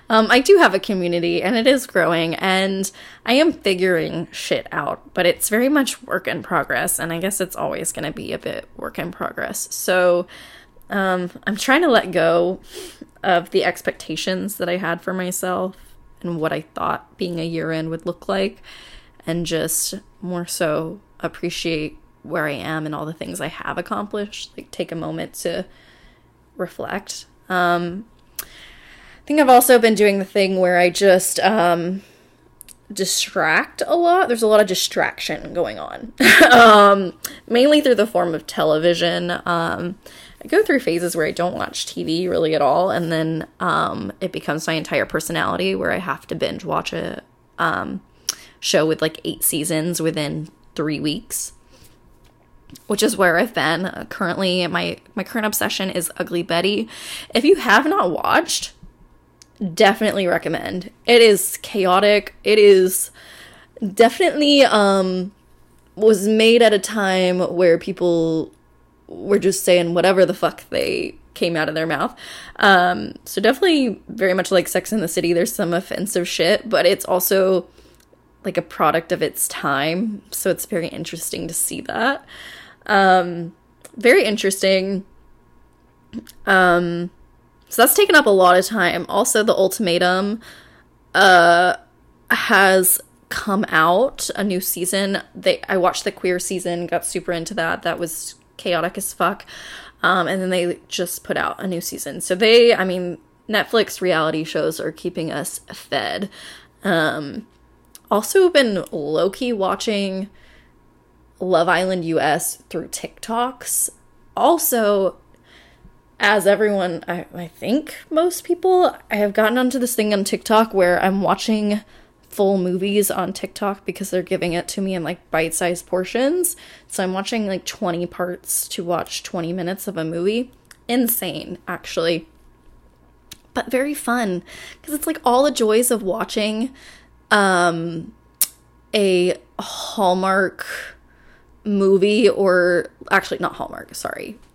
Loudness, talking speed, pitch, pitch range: -18 LUFS, 150 wpm, 185 Hz, 175-215 Hz